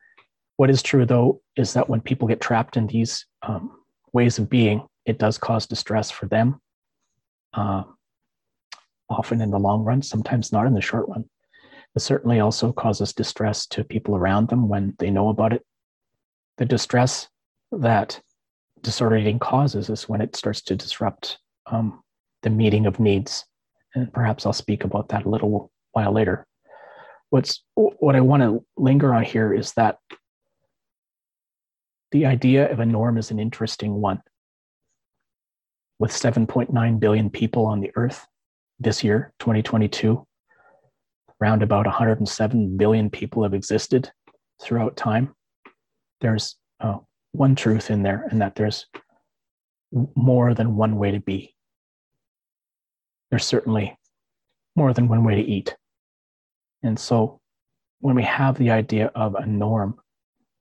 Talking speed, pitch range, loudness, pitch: 145 wpm, 105-120 Hz, -22 LUFS, 110 Hz